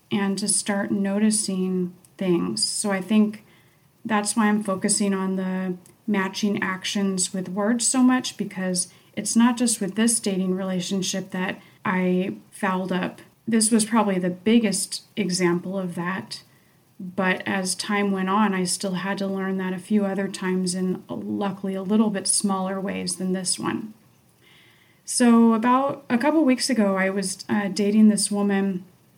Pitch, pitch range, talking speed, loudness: 195 Hz, 185-210 Hz, 160 wpm, -23 LUFS